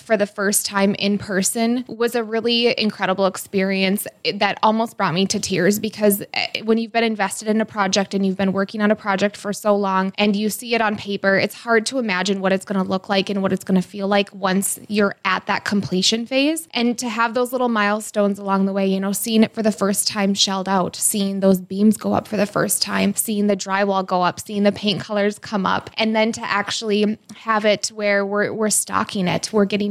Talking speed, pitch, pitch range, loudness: 235 wpm, 205 Hz, 195-220 Hz, -20 LUFS